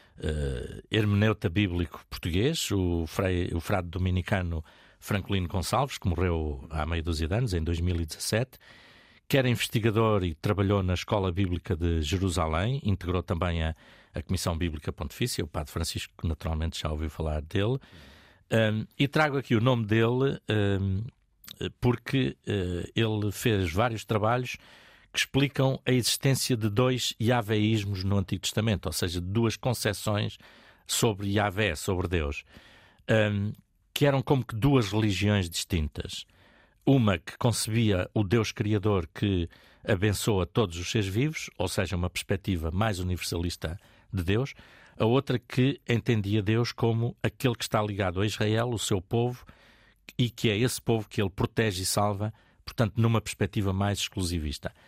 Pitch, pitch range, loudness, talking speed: 105 Hz, 90-115 Hz, -28 LUFS, 145 wpm